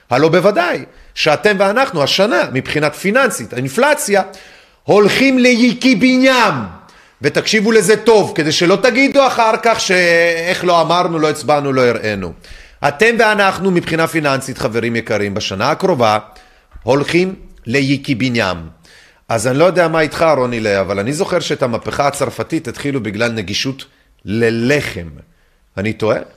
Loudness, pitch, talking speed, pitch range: -14 LUFS, 155 Hz, 125 wpm, 120-195 Hz